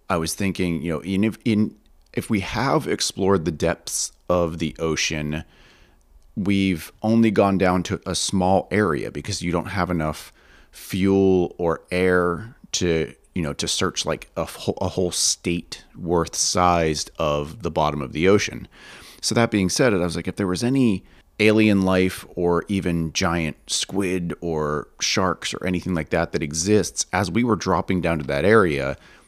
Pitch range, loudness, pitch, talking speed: 80-100 Hz, -22 LUFS, 90 Hz, 175 wpm